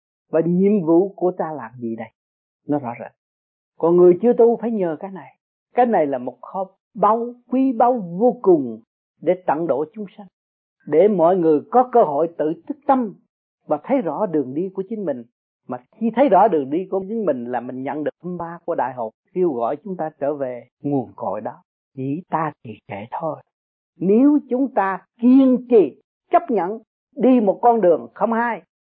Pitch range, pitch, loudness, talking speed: 145-235 Hz, 190 Hz, -19 LUFS, 200 wpm